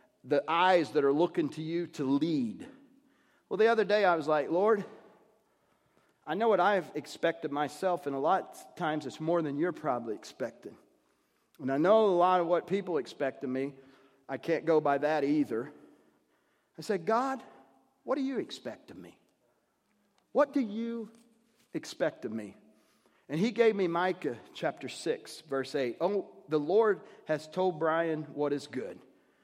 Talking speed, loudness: 170 wpm, -31 LUFS